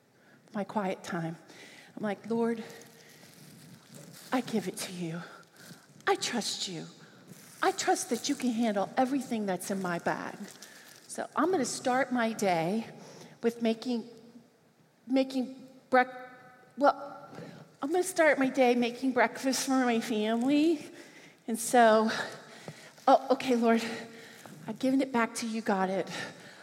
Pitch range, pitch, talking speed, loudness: 210-260 Hz, 230 Hz, 135 wpm, -30 LUFS